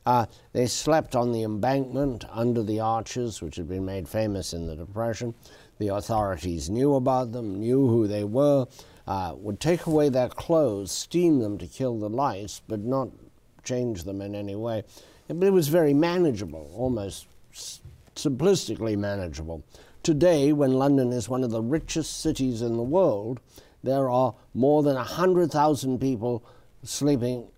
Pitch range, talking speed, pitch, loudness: 105-135 Hz, 160 wpm, 120 Hz, -26 LUFS